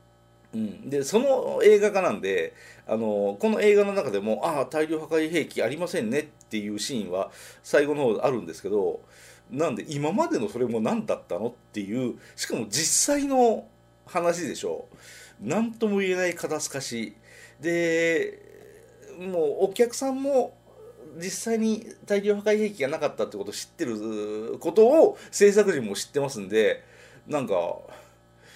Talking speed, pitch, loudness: 300 characters per minute, 205 Hz, -25 LUFS